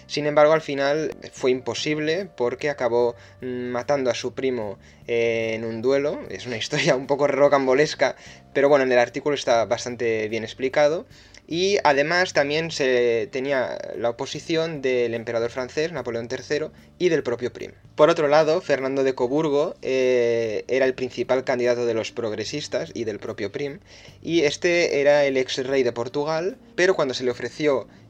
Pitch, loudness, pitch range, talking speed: 130 Hz, -23 LUFS, 120-150 Hz, 165 wpm